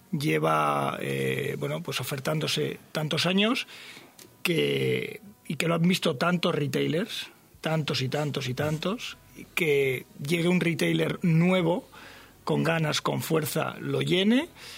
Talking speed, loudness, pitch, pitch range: 130 wpm, -27 LUFS, 160 Hz, 145-175 Hz